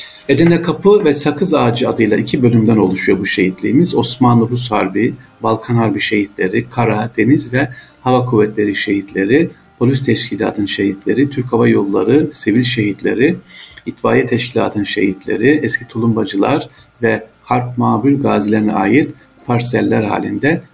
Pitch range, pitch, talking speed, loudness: 110-125 Hz, 115 Hz, 125 wpm, -14 LUFS